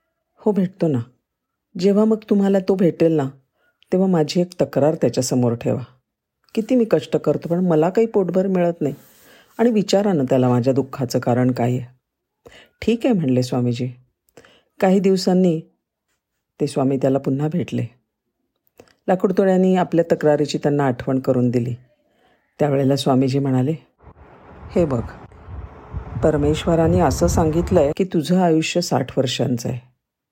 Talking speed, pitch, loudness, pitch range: 135 wpm, 150 Hz, -19 LUFS, 130-185 Hz